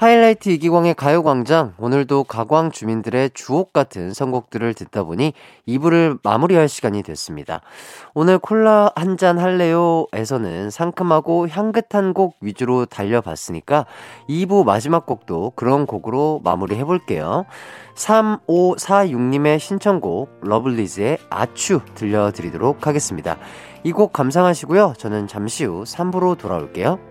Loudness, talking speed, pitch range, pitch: -18 LUFS, 305 characters per minute, 115-180 Hz, 145 Hz